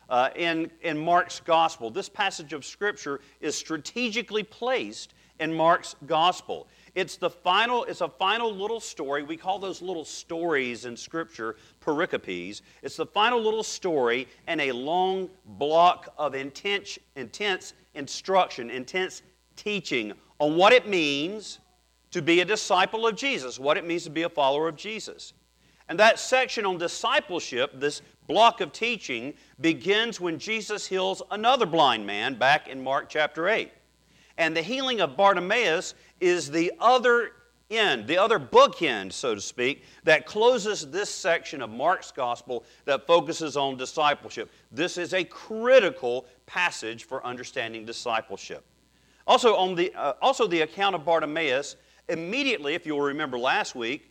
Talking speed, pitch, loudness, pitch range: 150 wpm, 170 Hz, -25 LUFS, 145-205 Hz